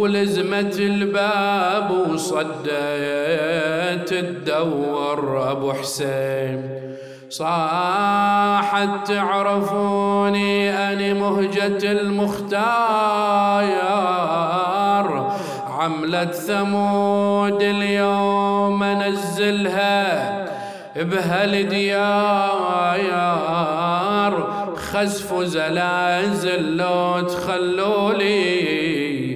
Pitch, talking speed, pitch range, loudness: 200 Hz, 45 wpm, 170-200 Hz, -20 LUFS